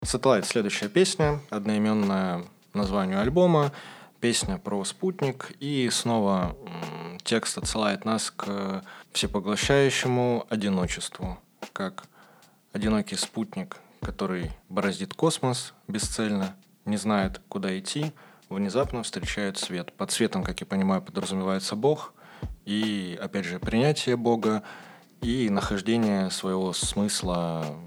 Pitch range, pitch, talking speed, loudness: 95-125 Hz, 105 Hz, 105 wpm, -27 LUFS